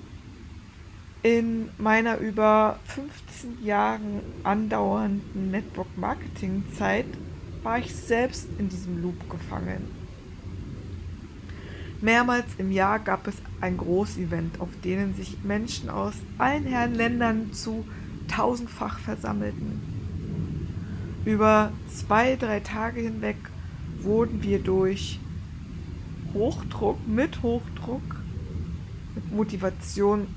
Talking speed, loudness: 90 wpm, -27 LUFS